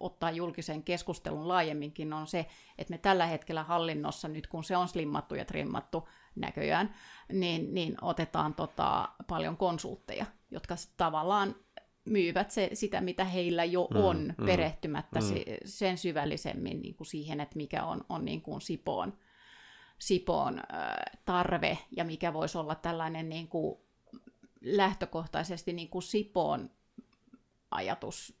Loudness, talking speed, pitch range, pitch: -34 LUFS, 130 wpm, 160-185 Hz, 175 Hz